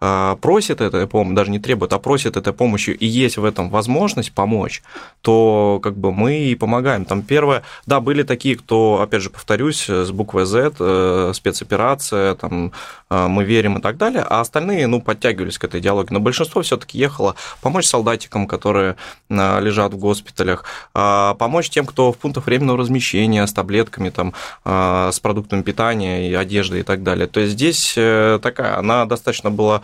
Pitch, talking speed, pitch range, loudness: 105 Hz, 170 wpm, 95-120 Hz, -17 LUFS